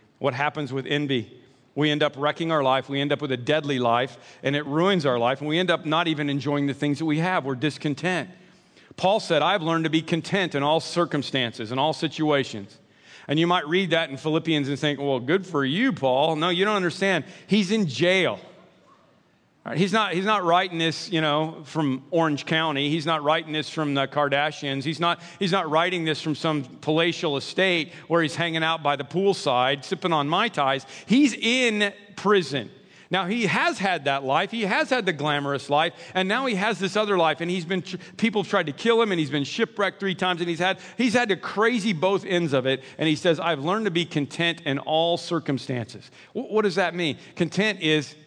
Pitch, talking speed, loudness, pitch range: 160 Hz, 215 wpm, -24 LUFS, 145-185 Hz